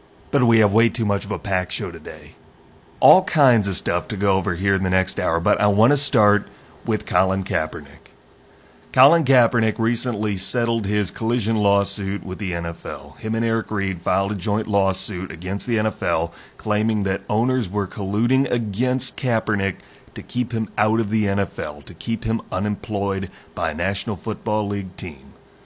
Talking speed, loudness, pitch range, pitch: 180 wpm, -21 LUFS, 95-115 Hz, 105 Hz